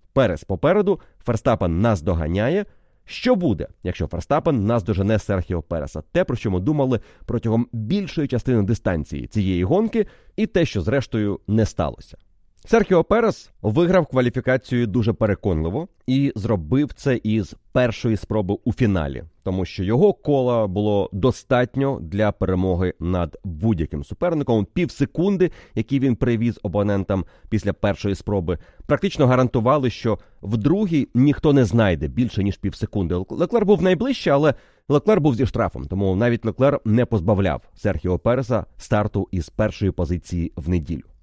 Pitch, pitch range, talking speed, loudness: 110 Hz, 95-135 Hz, 140 wpm, -21 LUFS